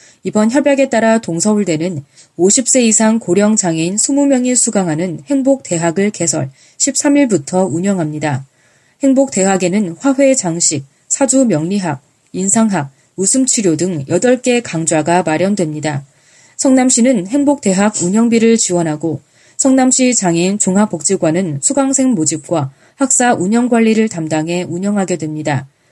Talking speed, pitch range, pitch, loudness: 285 characters per minute, 160-240 Hz, 185 Hz, -13 LUFS